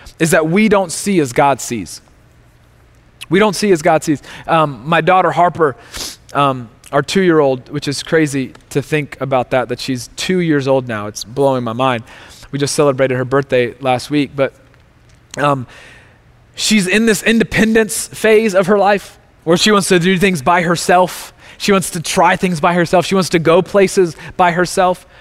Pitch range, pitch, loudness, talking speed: 130-185 Hz, 155 Hz, -14 LUFS, 190 wpm